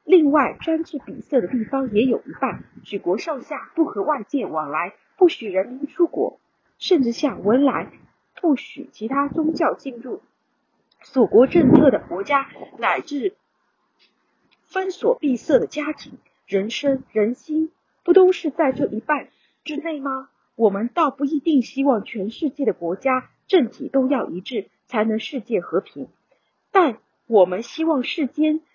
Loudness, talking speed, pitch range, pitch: -21 LUFS, 220 characters per minute, 240-315 Hz, 275 Hz